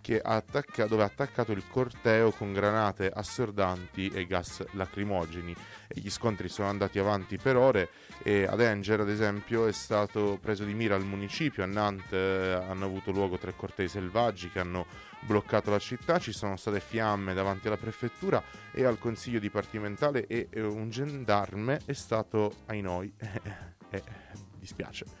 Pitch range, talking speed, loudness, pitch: 95-110 Hz, 155 wpm, -31 LUFS, 105 Hz